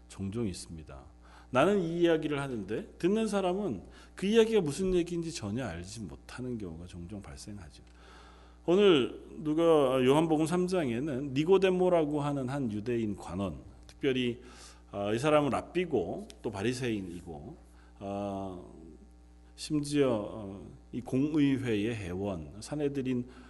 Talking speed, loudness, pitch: 265 characters per minute, -30 LUFS, 115 Hz